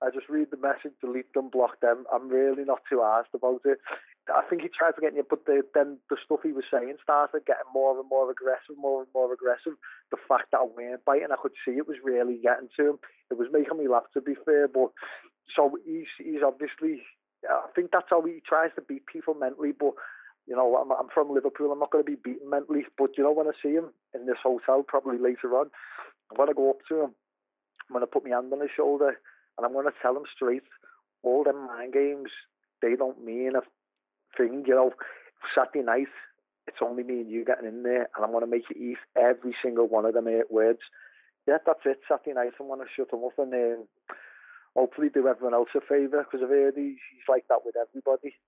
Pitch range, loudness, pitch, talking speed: 125-145 Hz, -27 LUFS, 135 Hz, 235 wpm